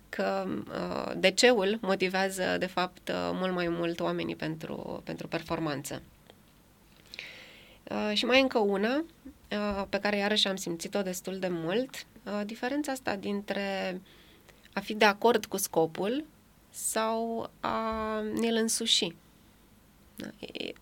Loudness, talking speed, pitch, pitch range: -30 LUFS, 130 wpm, 200 Hz, 180-225 Hz